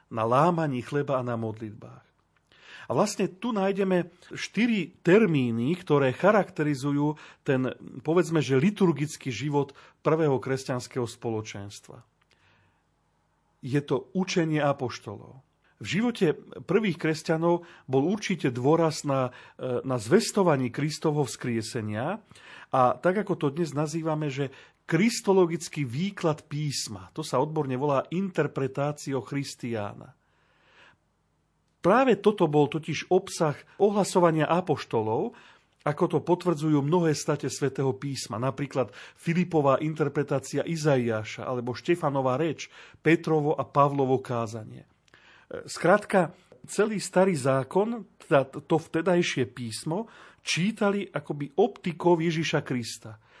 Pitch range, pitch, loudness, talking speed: 135-175 Hz, 150 Hz, -27 LUFS, 105 wpm